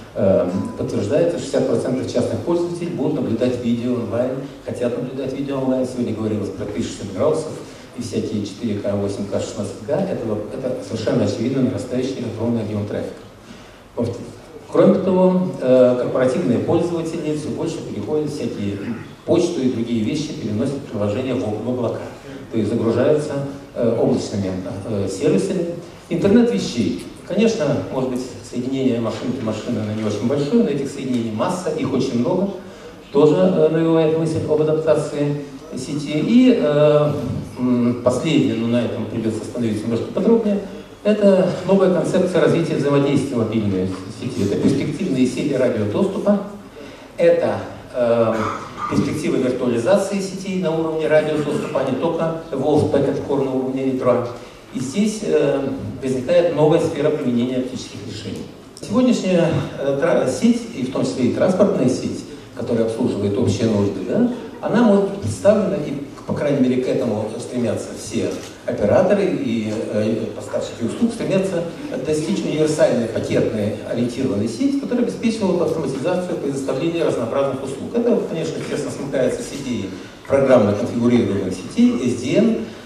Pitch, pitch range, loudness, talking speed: 135 Hz, 120-165 Hz, -20 LUFS, 130 wpm